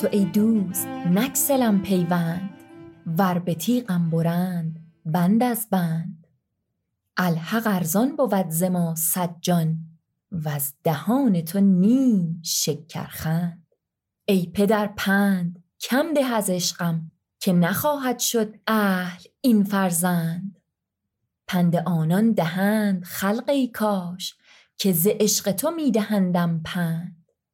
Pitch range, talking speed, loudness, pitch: 170-210 Hz, 105 wpm, -23 LUFS, 185 Hz